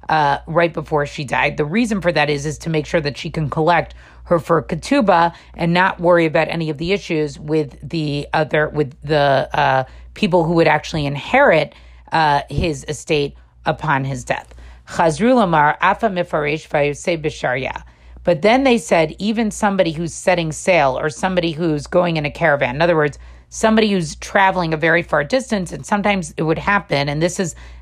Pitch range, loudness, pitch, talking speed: 150-180 Hz, -18 LUFS, 160 Hz, 175 wpm